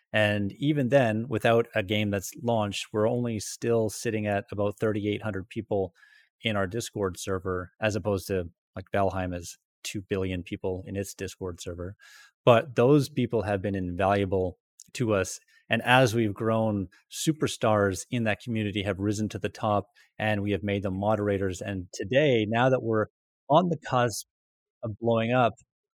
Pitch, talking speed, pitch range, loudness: 105 Hz, 165 wpm, 95-115 Hz, -27 LUFS